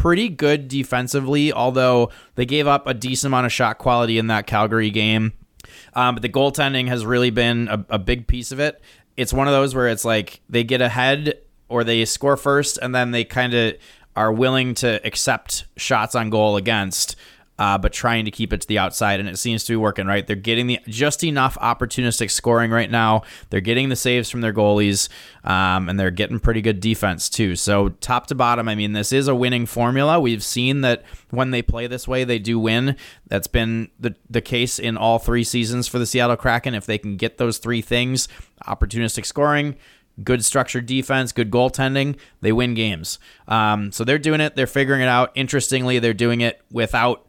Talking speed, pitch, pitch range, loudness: 205 wpm, 120 Hz, 110-130 Hz, -20 LUFS